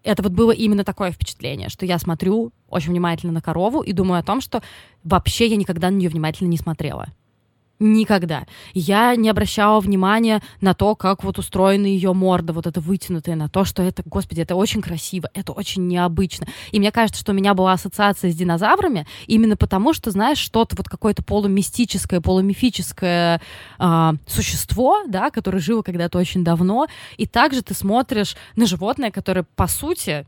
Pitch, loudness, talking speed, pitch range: 195 Hz, -19 LUFS, 175 wpm, 175-215 Hz